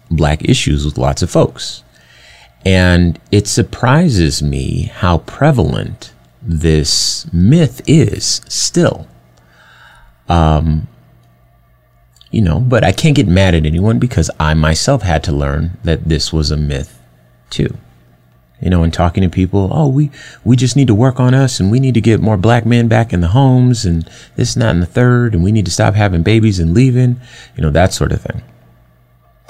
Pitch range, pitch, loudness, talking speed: 75-120 Hz, 90 Hz, -13 LUFS, 175 wpm